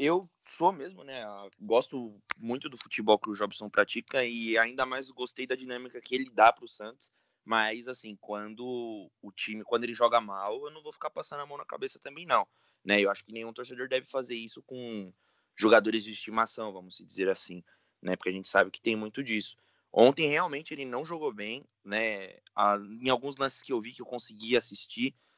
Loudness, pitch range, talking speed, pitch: -30 LUFS, 105-130 Hz, 205 wpm, 120 Hz